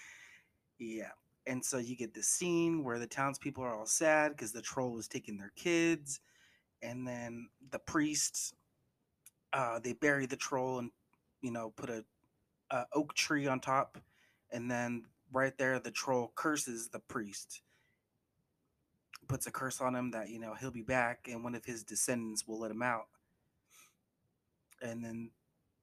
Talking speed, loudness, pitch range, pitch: 165 wpm, -37 LUFS, 115-135 Hz, 125 Hz